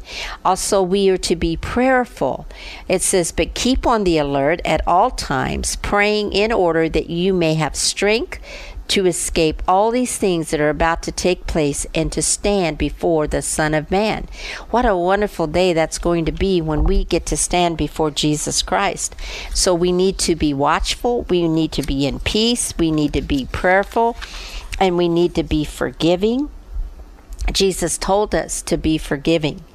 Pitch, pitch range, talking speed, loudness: 175 Hz, 155-195 Hz, 175 wpm, -18 LUFS